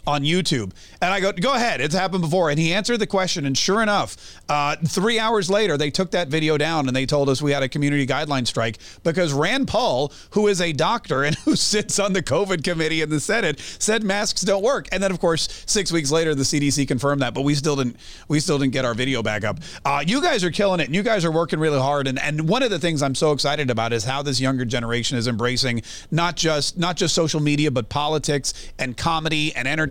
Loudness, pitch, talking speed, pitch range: -21 LUFS, 155 Hz, 245 wpm, 140-185 Hz